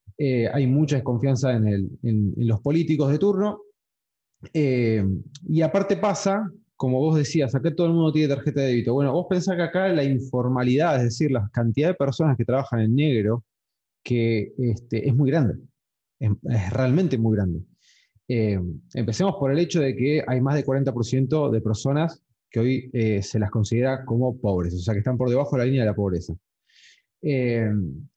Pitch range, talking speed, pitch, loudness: 115-150 Hz, 185 wpm, 130 Hz, -23 LUFS